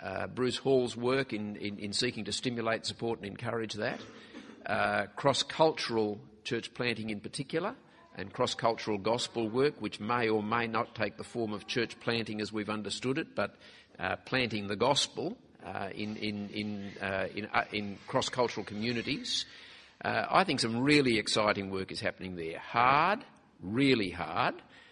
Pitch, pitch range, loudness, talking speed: 110 Hz, 105-120 Hz, -32 LUFS, 170 wpm